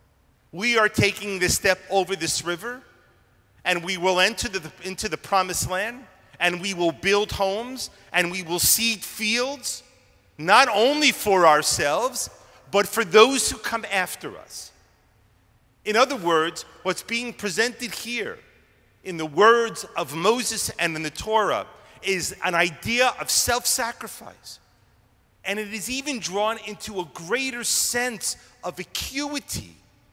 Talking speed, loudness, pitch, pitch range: 145 wpm, -22 LUFS, 195 Hz, 175-230 Hz